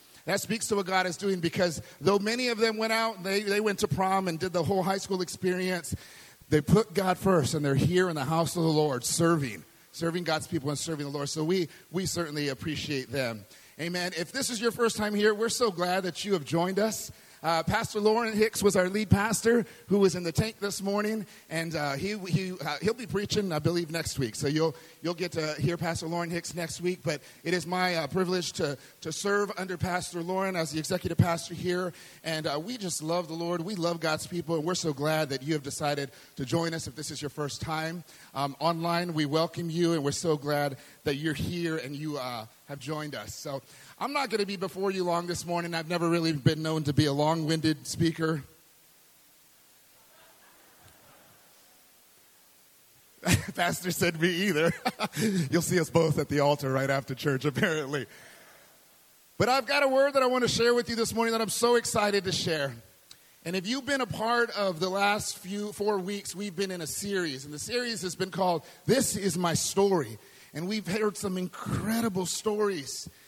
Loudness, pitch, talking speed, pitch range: -29 LUFS, 175 Hz, 215 wpm, 155-200 Hz